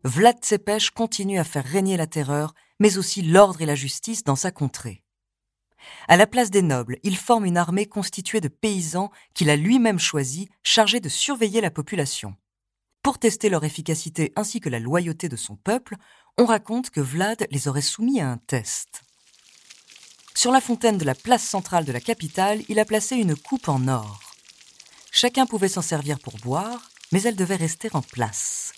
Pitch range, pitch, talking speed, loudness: 145-220 Hz, 185 Hz, 185 wpm, -22 LUFS